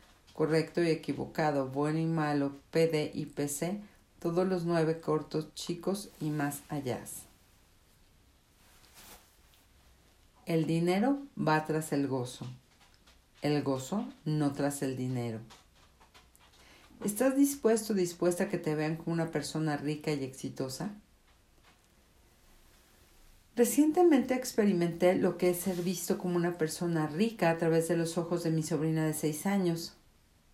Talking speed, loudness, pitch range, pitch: 130 wpm, -31 LUFS, 130-175 Hz, 155 Hz